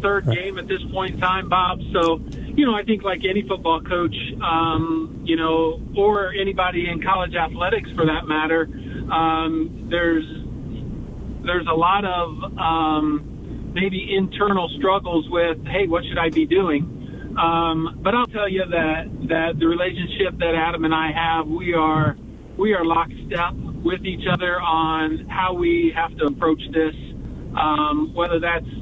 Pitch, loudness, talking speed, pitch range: 165 Hz, -21 LUFS, 160 wpm, 160-185 Hz